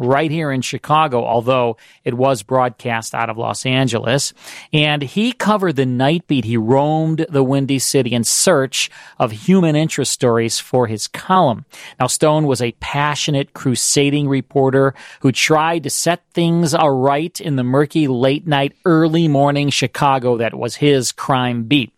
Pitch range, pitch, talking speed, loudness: 125-155 Hz, 140 Hz, 160 wpm, -16 LUFS